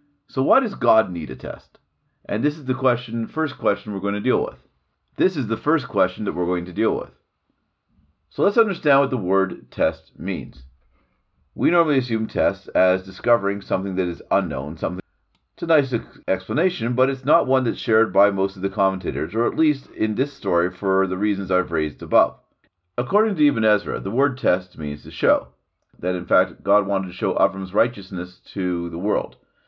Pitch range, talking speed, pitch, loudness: 90-130 Hz, 200 wpm, 100 Hz, -22 LUFS